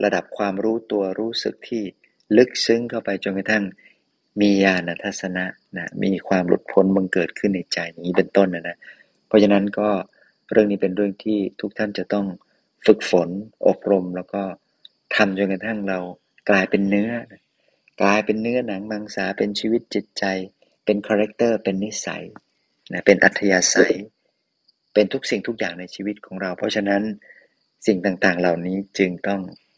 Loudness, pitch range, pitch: -21 LUFS, 95-105 Hz, 100 Hz